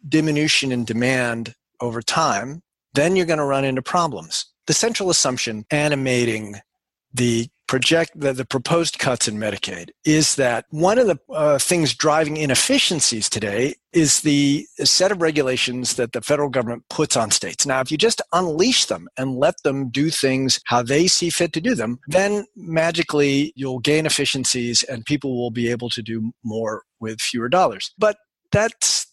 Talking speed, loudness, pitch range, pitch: 170 wpm, -19 LUFS, 120-155 Hz, 135 Hz